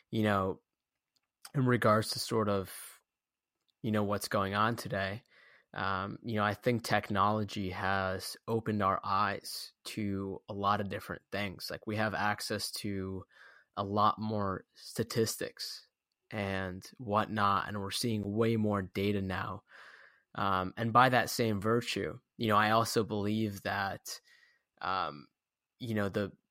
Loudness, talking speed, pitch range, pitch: -33 LUFS, 145 wpm, 100-110 Hz, 105 Hz